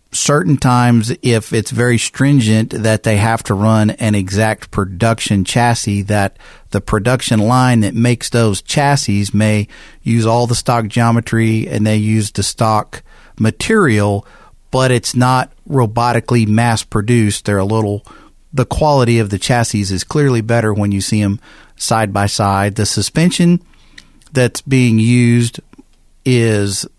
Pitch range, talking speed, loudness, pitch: 105-120 Hz, 145 wpm, -14 LUFS, 115 Hz